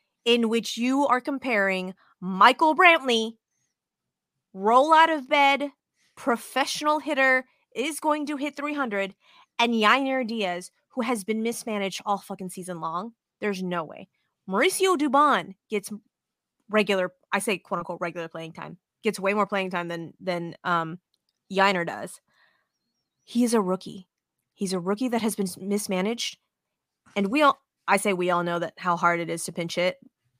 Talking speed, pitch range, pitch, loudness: 150 wpm, 185-255 Hz, 210 Hz, -24 LUFS